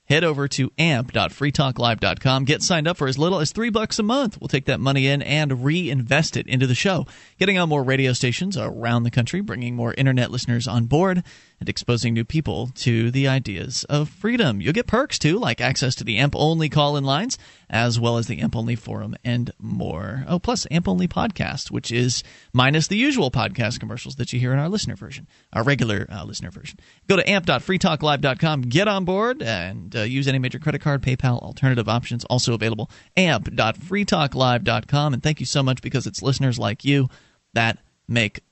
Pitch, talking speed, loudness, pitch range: 135 Hz, 195 wpm, -21 LUFS, 120-155 Hz